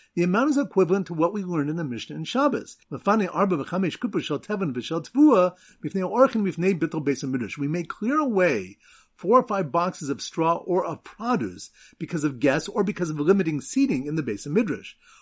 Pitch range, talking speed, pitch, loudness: 160-210 Hz, 155 wpm, 180 Hz, -24 LUFS